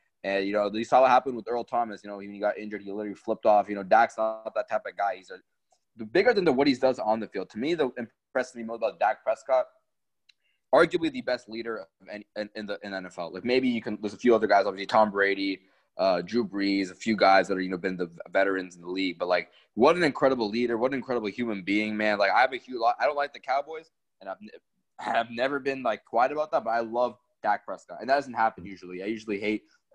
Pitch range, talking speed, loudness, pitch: 100-120 Hz, 260 wpm, -27 LUFS, 110 Hz